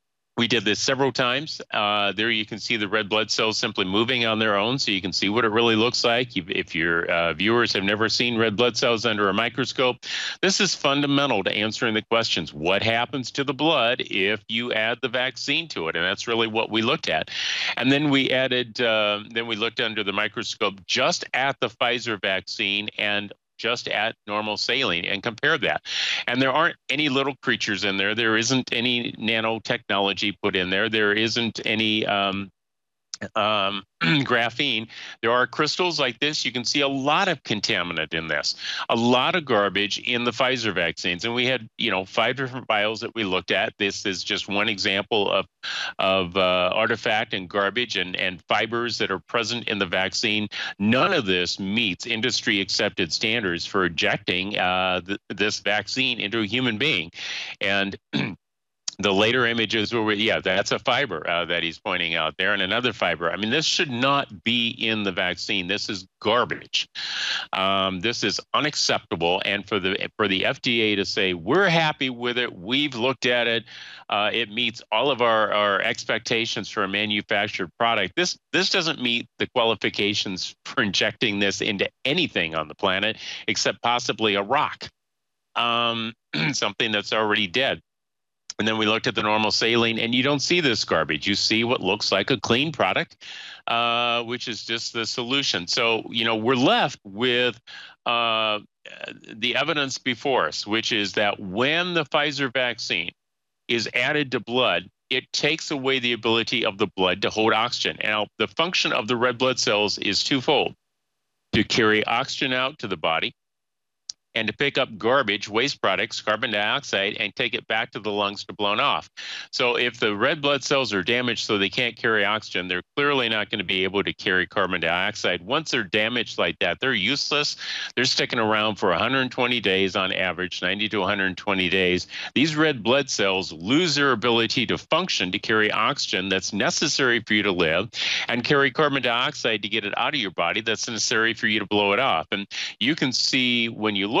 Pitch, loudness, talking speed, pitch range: 115 Hz, -22 LUFS, 190 wpm, 100-125 Hz